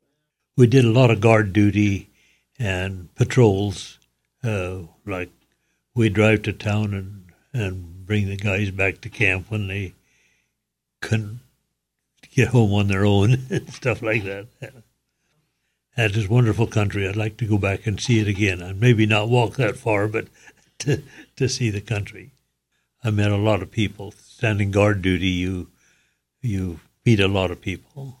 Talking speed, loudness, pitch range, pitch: 160 wpm, -21 LUFS, 95-115 Hz, 105 Hz